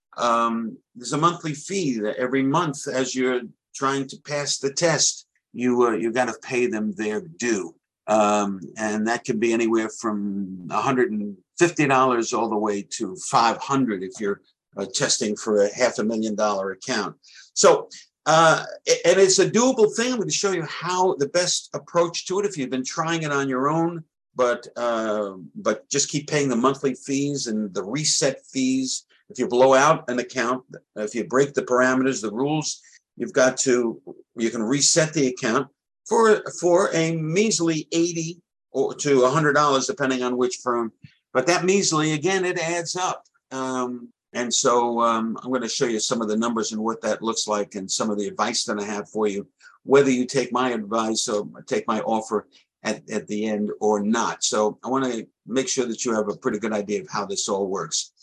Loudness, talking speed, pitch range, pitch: -22 LUFS, 195 wpm, 110-155 Hz, 125 Hz